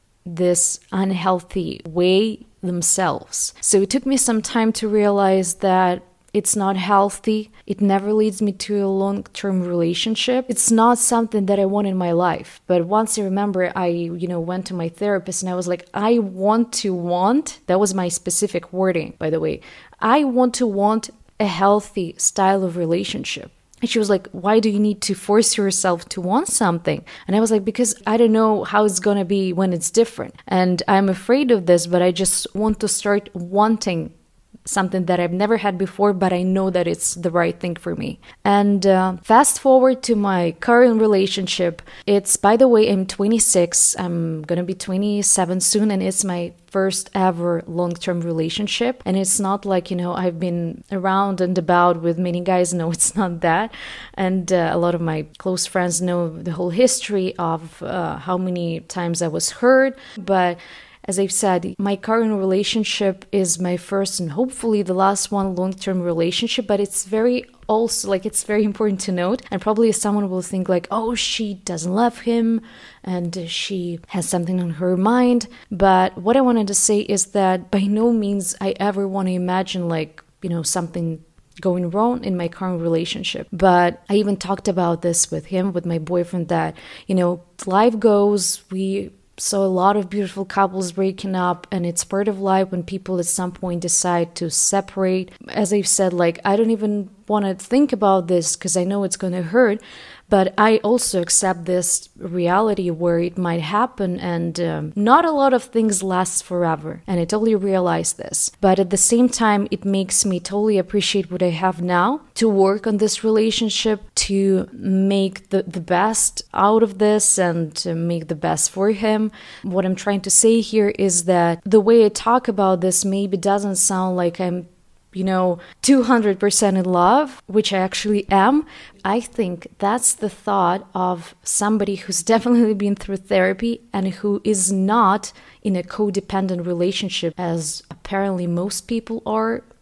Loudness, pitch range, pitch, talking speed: -19 LUFS, 180-210 Hz, 195 Hz, 185 wpm